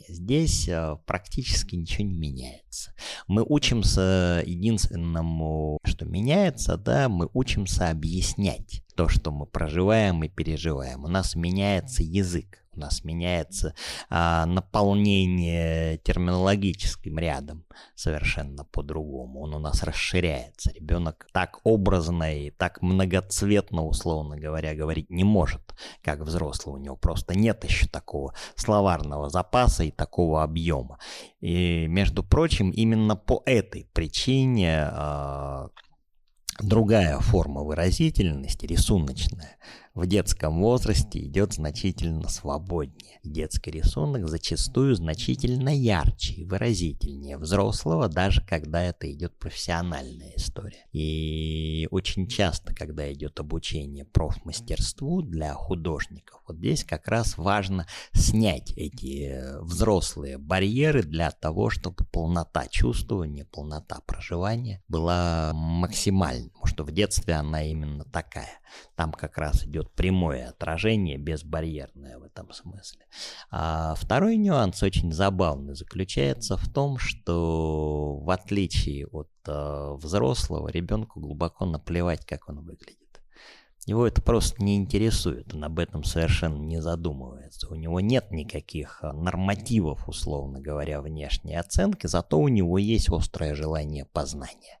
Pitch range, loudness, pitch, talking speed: 75-95 Hz, -27 LUFS, 85 Hz, 120 wpm